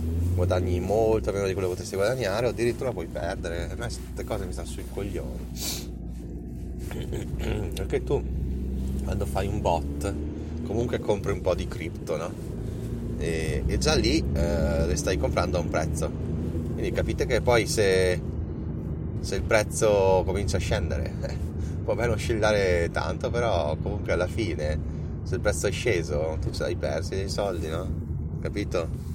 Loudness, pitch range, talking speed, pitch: -27 LUFS, 75-95 Hz, 160 wpm, 85 Hz